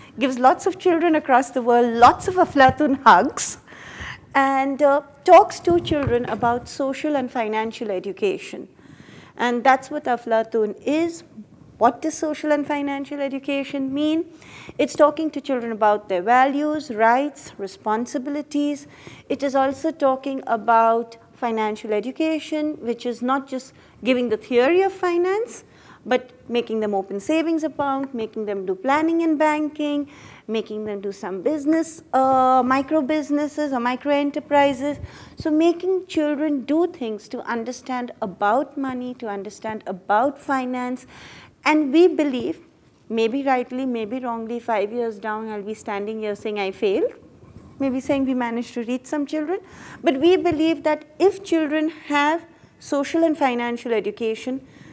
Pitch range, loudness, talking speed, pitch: 235-305 Hz, -21 LUFS, 140 wpm, 270 Hz